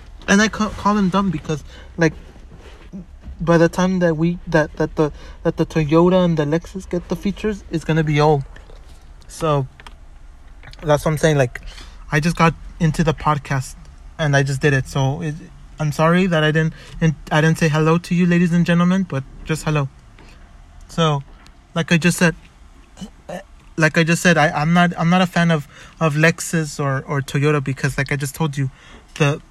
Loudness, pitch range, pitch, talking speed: -18 LUFS, 140-170 Hz, 155 Hz, 190 wpm